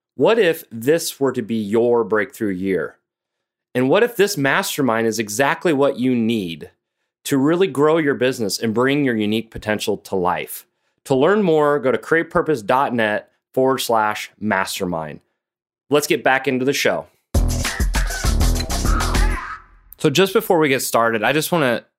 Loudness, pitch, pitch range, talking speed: -19 LUFS, 130 Hz, 115-155 Hz, 155 wpm